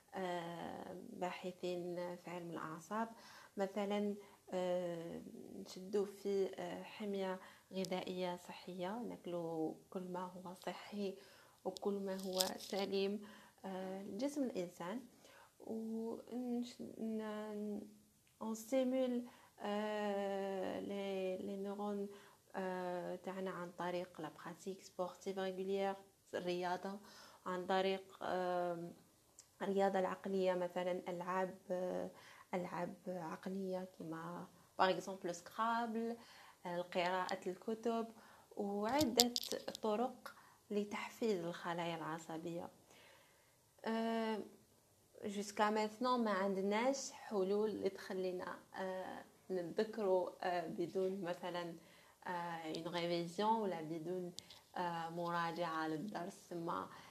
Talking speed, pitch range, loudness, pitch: 75 wpm, 180-210 Hz, -42 LUFS, 190 Hz